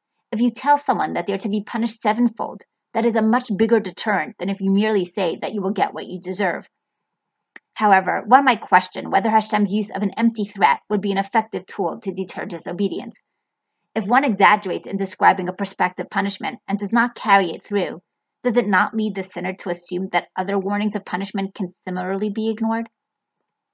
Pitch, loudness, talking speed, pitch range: 205 Hz, -21 LUFS, 200 wpm, 190-225 Hz